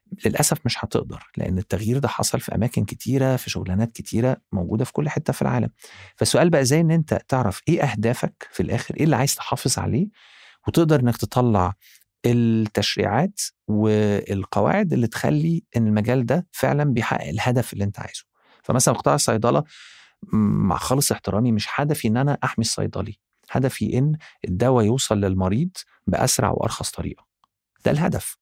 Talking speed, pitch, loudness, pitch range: 150 wpm, 120 Hz, -22 LUFS, 105-140 Hz